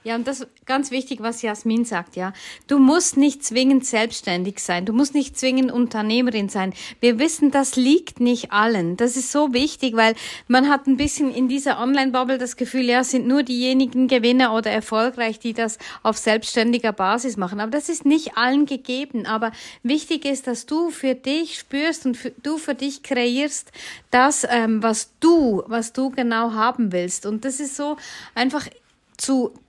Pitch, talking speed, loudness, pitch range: 255 Hz, 185 wpm, -20 LUFS, 225-275 Hz